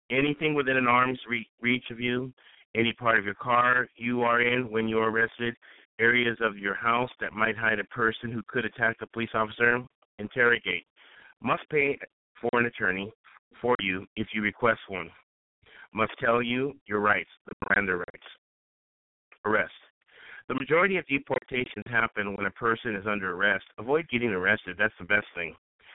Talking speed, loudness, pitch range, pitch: 170 wpm, -27 LUFS, 110-125 Hz, 115 Hz